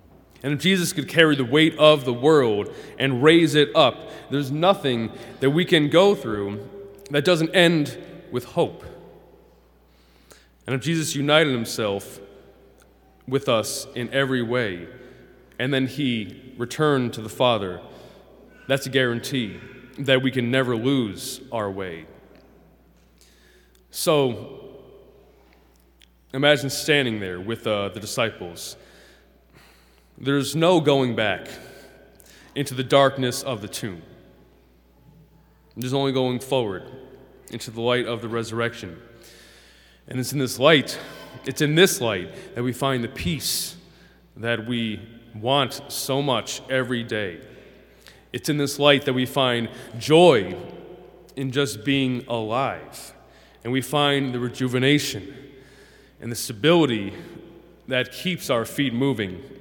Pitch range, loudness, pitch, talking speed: 115-140 Hz, -22 LUFS, 130 Hz, 130 wpm